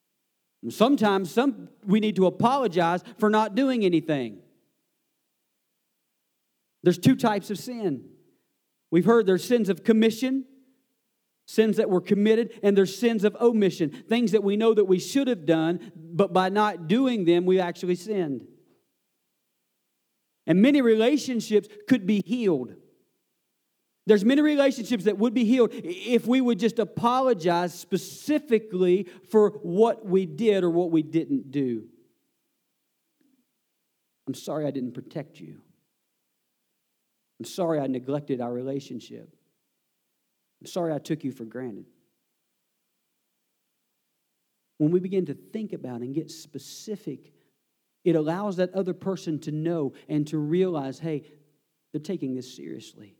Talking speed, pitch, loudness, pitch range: 135 wpm, 190 Hz, -24 LUFS, 160-225 Hz